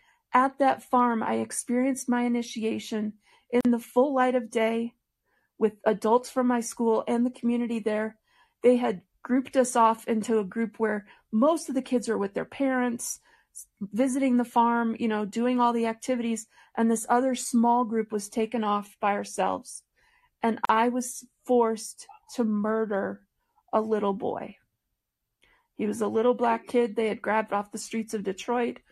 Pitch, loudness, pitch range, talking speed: 235 Hz, -27 LUFS, 220-250 Hz, 170 wpm